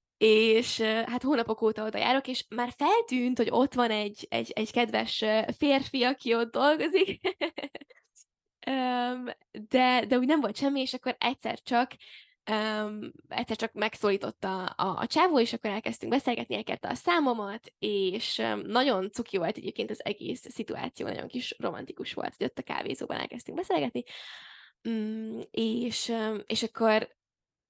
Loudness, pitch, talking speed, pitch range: -29 LUFS, 240 Hz, 140 wpm, 220-255 Hz